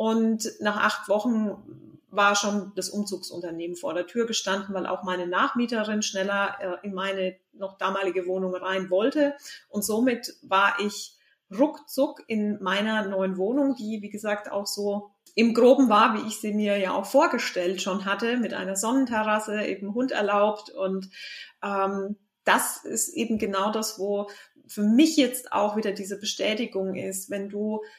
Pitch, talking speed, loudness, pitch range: 205 Hz, 160 wpm, -26 LUFS, 195-220 Hz